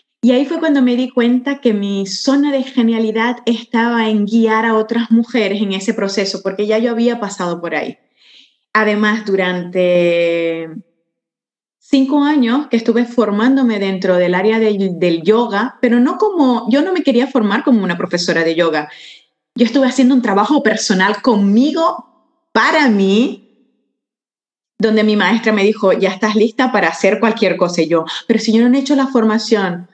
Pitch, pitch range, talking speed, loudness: 225 Hz, 195-250 Hz, 170 wpm, -14 LUFS